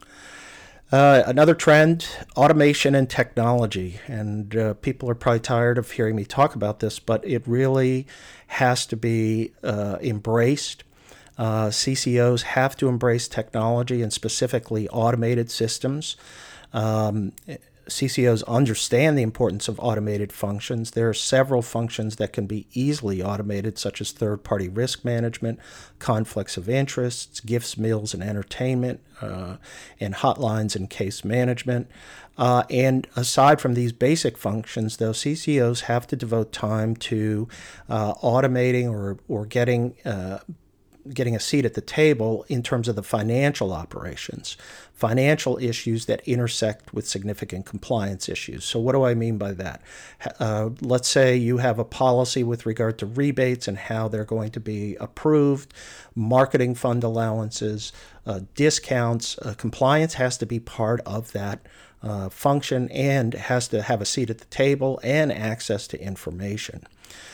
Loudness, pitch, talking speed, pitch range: -23 LUFS, 115 Hz, 145 wpm, 110-130 Hz